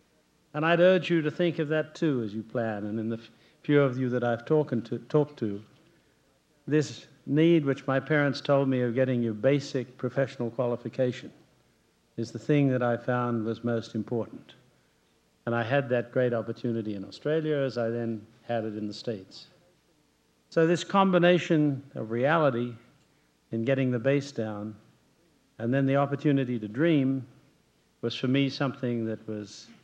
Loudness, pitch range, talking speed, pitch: -28 LUFS, 115-145 Hz, 170 wpm, 130 Hz